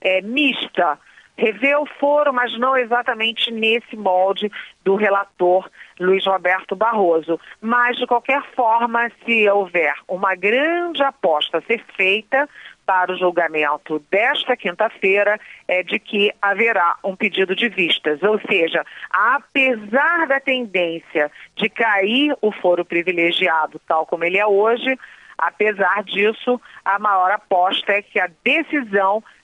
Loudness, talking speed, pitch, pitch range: -18 LUFS, 135 wpm, 210 Hz, 185-245 Hz